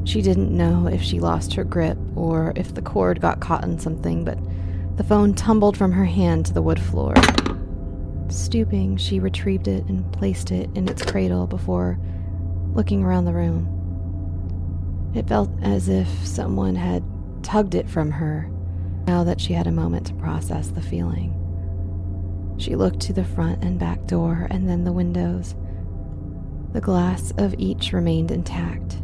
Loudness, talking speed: -22 LUFS, 165 wpm